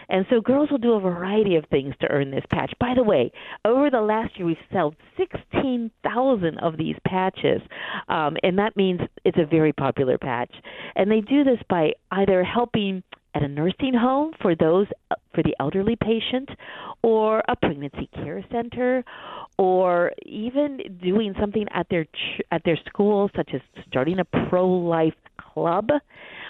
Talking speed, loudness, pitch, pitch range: 175 wpm, -23 LUFS, 195 Hz, 170-235 Hz